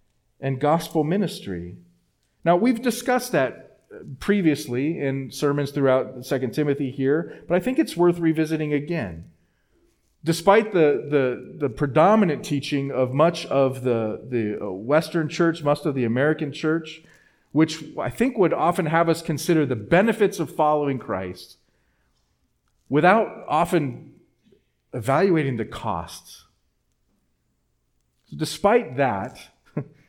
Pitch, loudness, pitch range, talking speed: 150 Hz, -22 LUFS, 125-165 Hz, 120 wpm